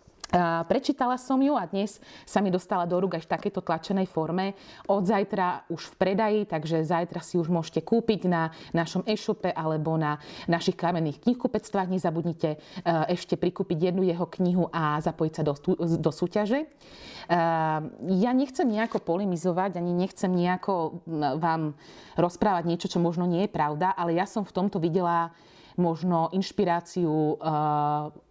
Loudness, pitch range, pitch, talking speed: -27 LUFS, 165-195 Hz, 175 Hz, 145 wpm